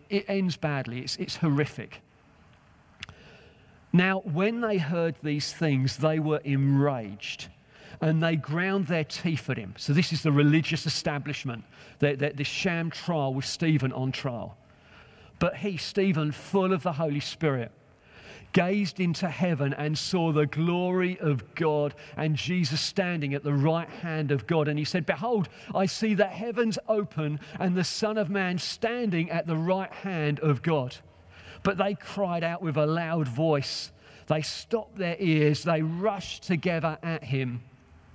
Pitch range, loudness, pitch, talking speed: 145-180 Hz, -28 LUFS, 160 Hz, 155 wpm